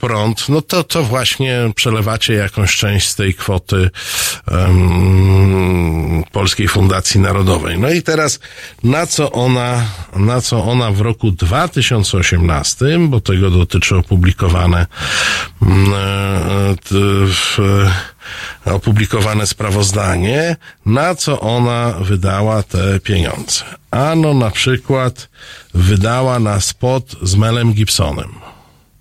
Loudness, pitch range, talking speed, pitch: -14 LUFS, 95-120 Hz, 105 wpm, 105 Hz